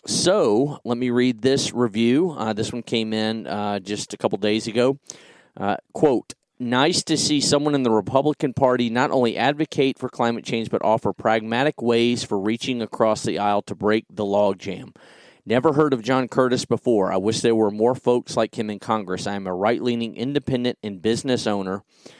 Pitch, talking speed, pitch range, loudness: 115 Hz, 190 wpm, 110-130 Hz, -22 LUFS